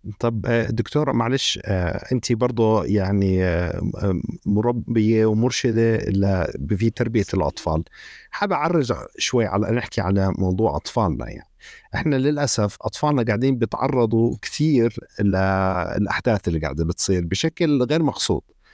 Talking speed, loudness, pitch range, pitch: 110 wpm, -21 LUFS, 95-120 Hz, 110 Hz